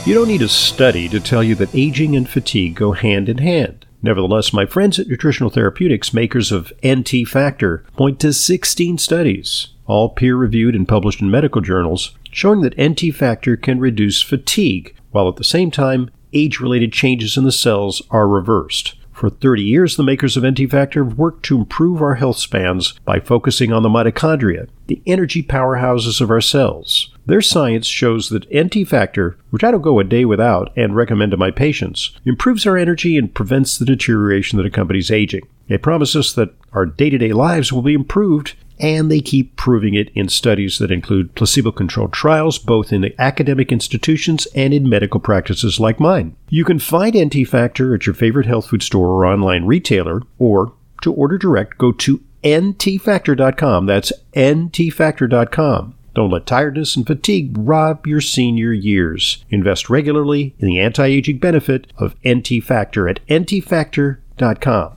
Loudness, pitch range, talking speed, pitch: -15 LUFS, 110-150 Hz, 175 wpm, 125 Hz